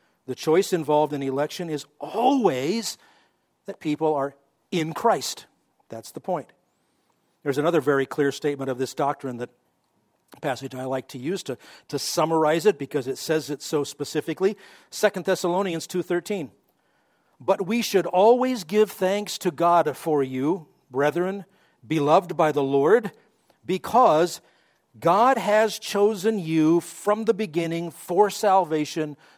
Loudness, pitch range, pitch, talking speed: -24 LUFS, 145-195 Hz, 165 Hz, 140 wpm